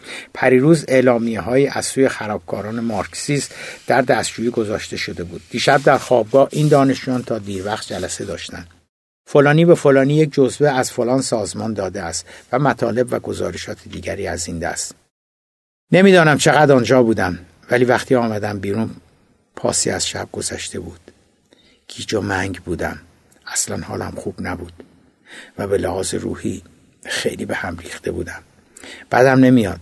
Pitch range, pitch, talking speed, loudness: 105-135 Hz, 125 Hz, 145 wpm, -18 LUFS